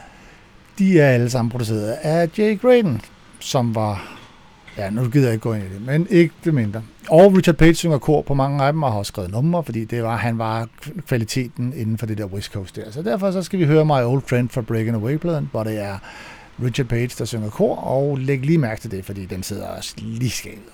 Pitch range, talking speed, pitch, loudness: 110-155 Hz, 235 wpm, 125 Hz, -20 LUFS